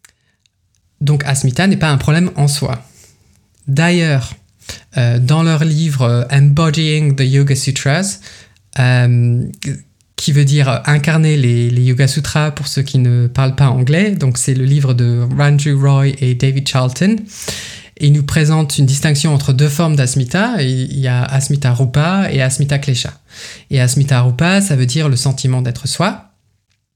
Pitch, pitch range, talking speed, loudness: 135 Hz, 125-150 Hz, 160 wpm, -13 LUFS